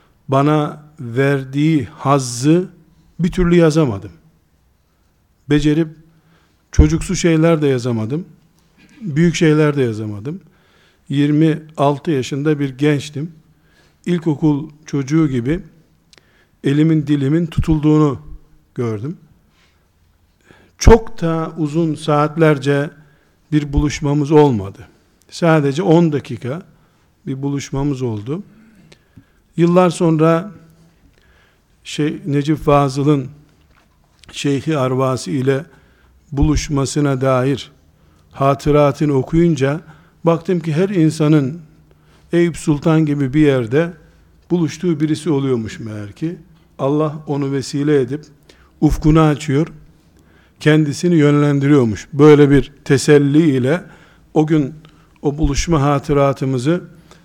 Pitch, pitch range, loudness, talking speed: 150 Hz, 135-160 Hz, -16 LUFS, 85 wpm